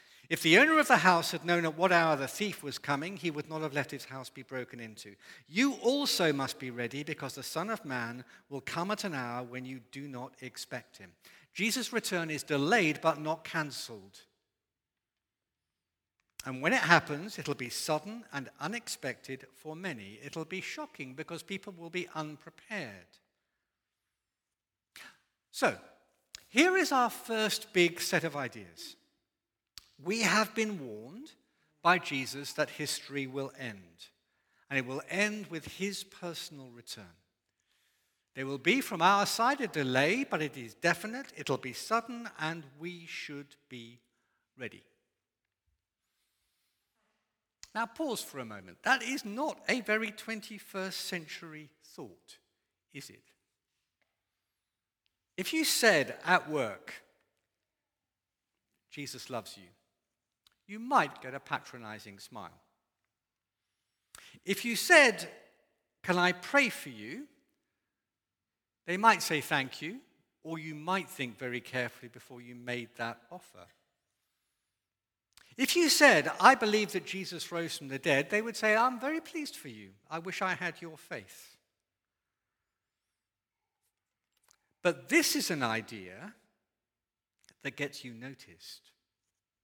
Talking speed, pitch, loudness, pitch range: 140 wpm, 155 Hz, -31 LUFS, 125-200 Hz